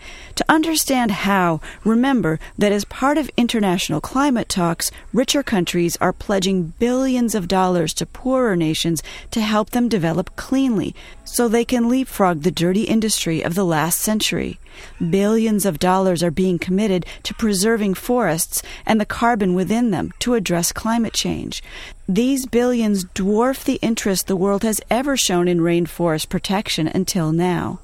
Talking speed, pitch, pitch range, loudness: 150 wpm, 205 Hz, 180-235 Hz, -19 LUFS